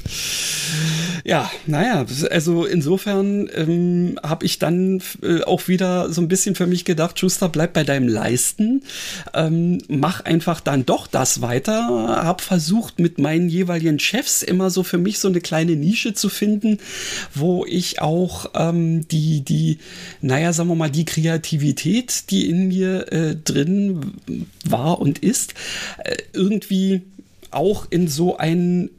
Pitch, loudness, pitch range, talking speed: 175 Hz, -20 LUFS, 160-190 Hz, 145 wpm